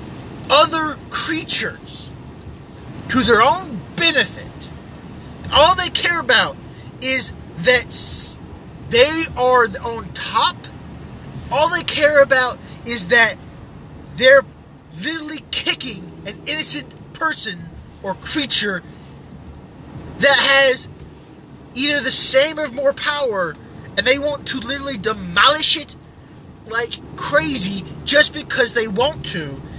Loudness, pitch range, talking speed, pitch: -16 LUFS, 235-295 Hz, 105 wpm, 265 Hz